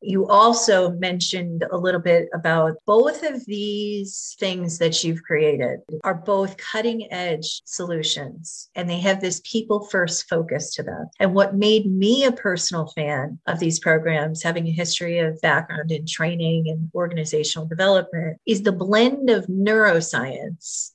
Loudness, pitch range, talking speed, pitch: -21 LUFS, 165-205 Hz, 150 wpm, 180 Hz